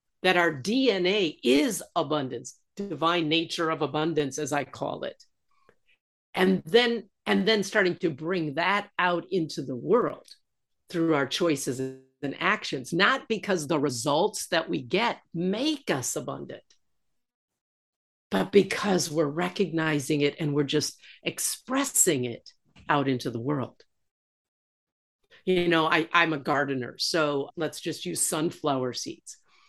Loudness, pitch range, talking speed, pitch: -26 LUFS, 145-185 Hz, 135 wpm, 165 Hz